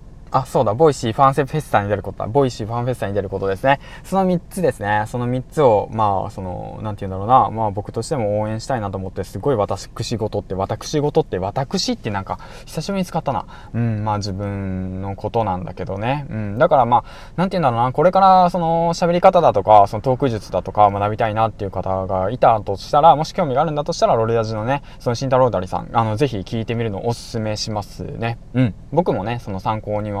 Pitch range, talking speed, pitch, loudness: 100-140 Hz, 475 characters per minute, 115 Hz, -19 LUFS